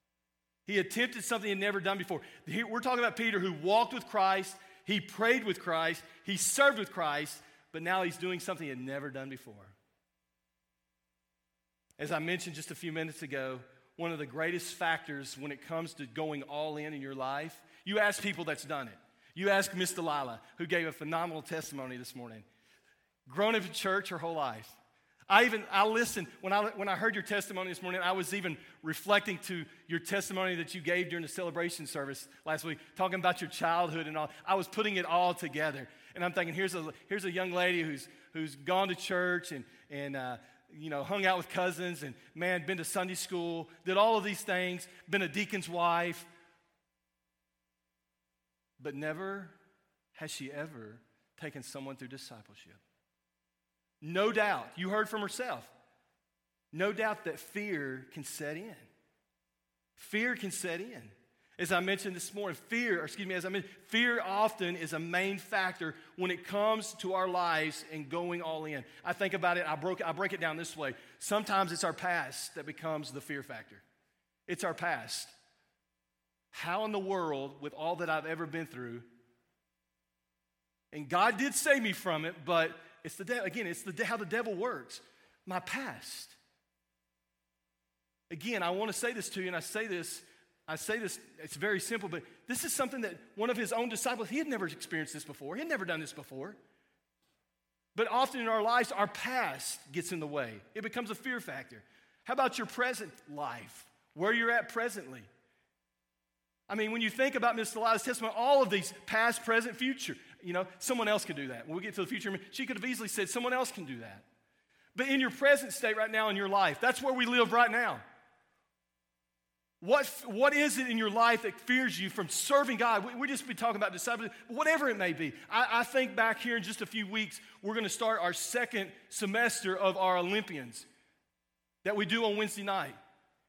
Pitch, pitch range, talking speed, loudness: 180 Hz, 145-210 Hz, 195 wpm, -33 LUFS